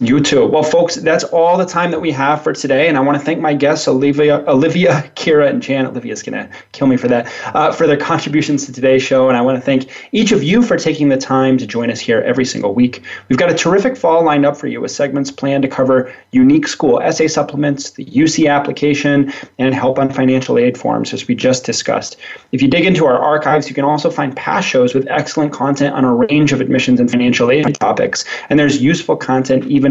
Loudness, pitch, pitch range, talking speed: -13 LUFS, 145 Hz, 130-160 Hz, 235 wpm